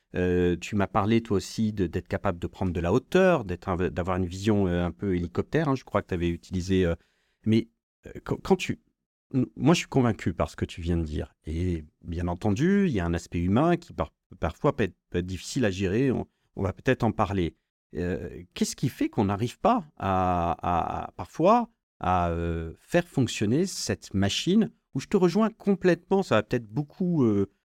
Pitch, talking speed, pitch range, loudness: 100 Hz, 195 wpm, 90-150 Hz, -27 LUFS